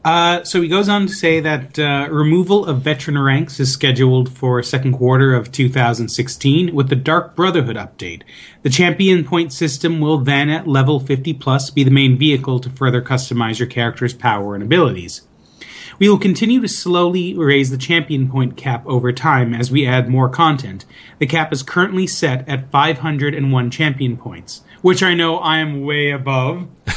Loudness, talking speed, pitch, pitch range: -16 LUFS, 180 wpm, 140 Hz, 130-165 Hz